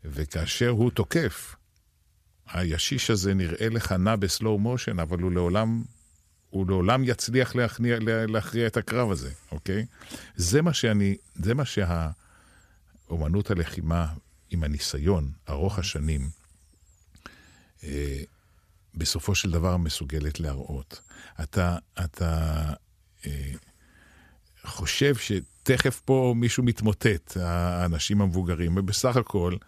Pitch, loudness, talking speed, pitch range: 90 Hz, -27 LUFS, 100 wpm, 80-110 Hz